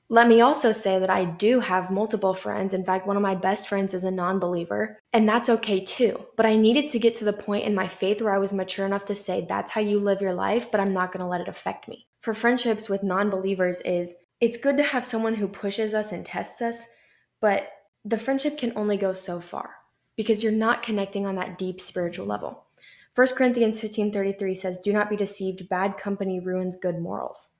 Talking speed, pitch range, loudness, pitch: 225 wpm, 185-225 Hz, -24 LUFS, 200 Hz